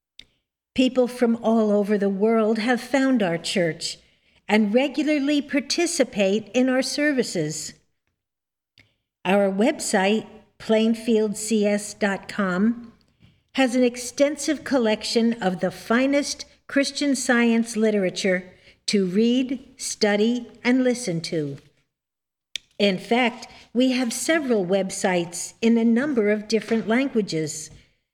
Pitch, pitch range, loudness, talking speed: 220 Hz, 195-250 Hz, -22 LUFS, 100 wpm